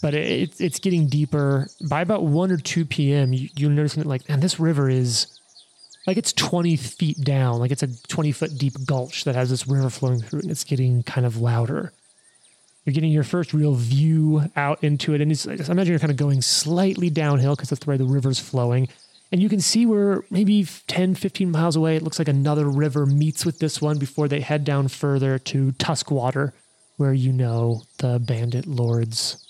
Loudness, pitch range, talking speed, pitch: -22 LUFS, 130-160 Hz, 205 wpm, 145 Hz